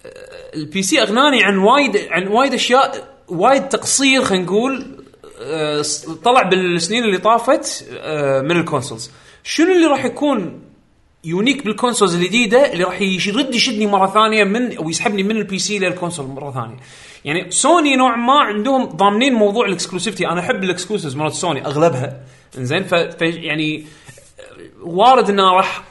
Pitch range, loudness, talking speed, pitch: 170-255 Hz, -15 LUFS, 140 wpm, 200 Hz